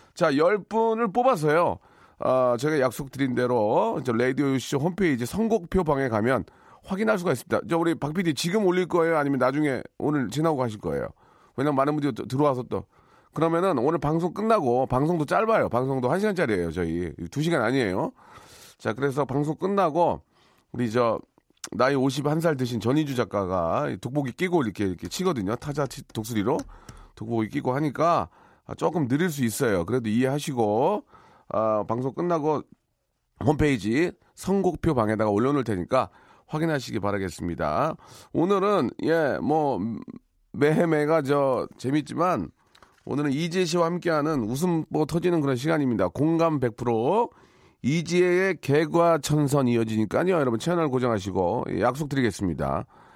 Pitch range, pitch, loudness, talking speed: 120-165 Hz, 145 Hz, -25 LUFS, 335 characters per minute